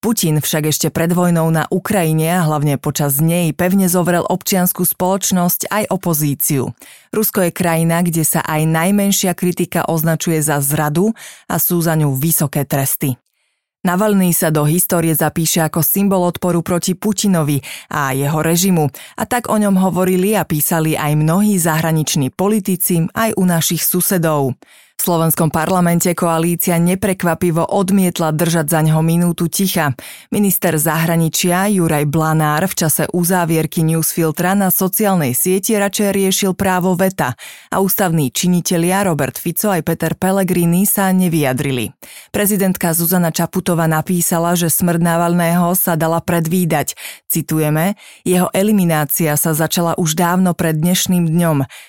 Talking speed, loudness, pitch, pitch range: 135 wpm, -15 LUFS, 170 Hz, 160-185 Hz